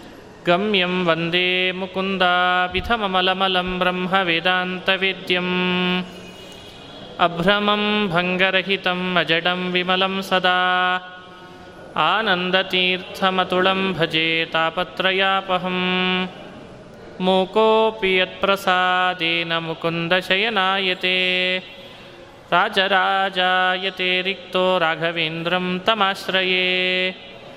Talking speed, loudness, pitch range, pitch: 45 wpm, -19 LUFS, 180-190 Hz, 185 Hz